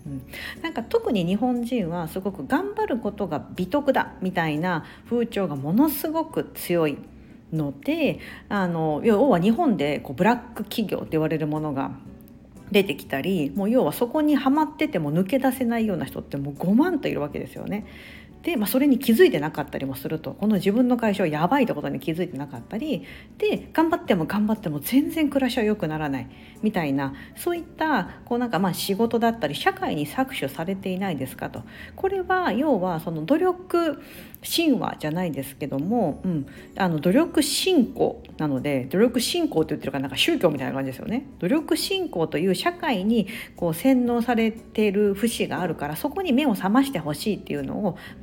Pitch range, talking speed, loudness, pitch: 160-270 Hz, 375 characters per minute, -24 LUFS, 215 Hz